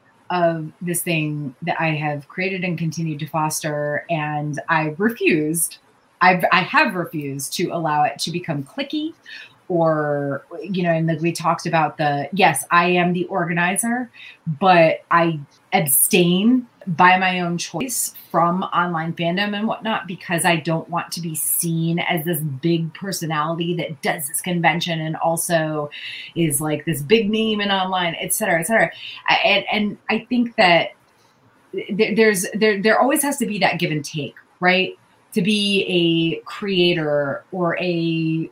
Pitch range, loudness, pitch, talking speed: 160-190 Hz, -20 LUFS, 170 Hz, 160 wpm